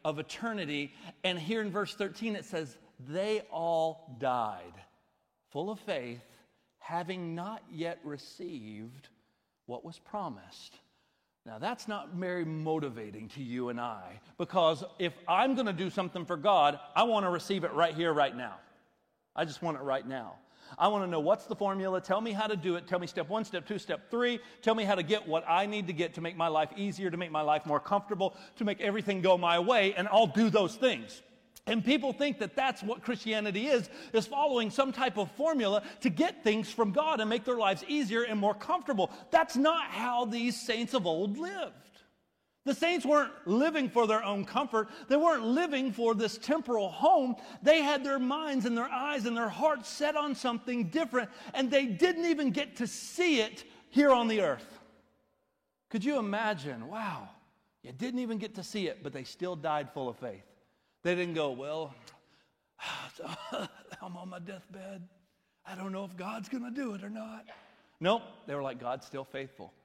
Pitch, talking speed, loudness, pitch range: 205 Hz, 195 wpm, -31 LUFS, 170-245 Hz